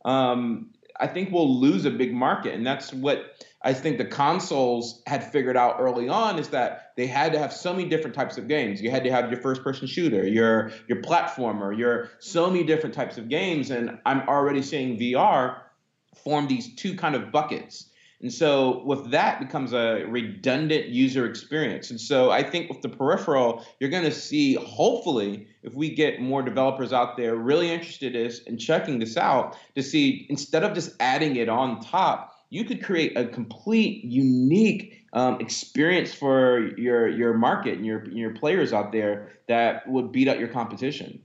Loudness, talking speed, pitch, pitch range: -24 LUFS, 190 wpm, 130 Hz, 120-155 Hz